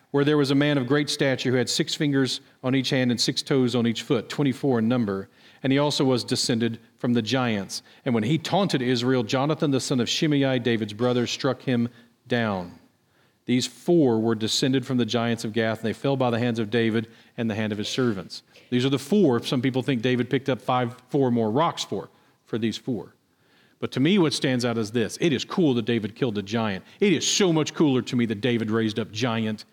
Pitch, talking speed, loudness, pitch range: 125 Hz, 235 wpm, -24 LUFS, 115-135 Hz